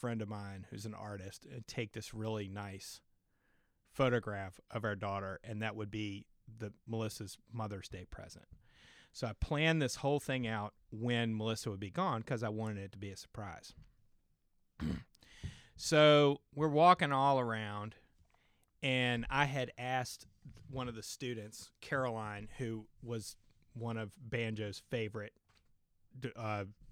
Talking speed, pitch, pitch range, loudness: 145 wpm, 110 Hz, 105-125 Hz, -37 LUFS